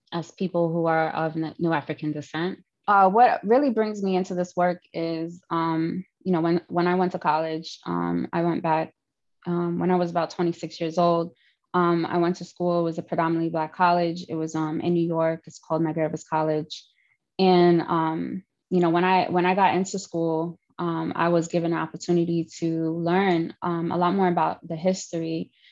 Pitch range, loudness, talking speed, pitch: 160-180 Hz, -24 LUFS, 200 wpm, 170 Hz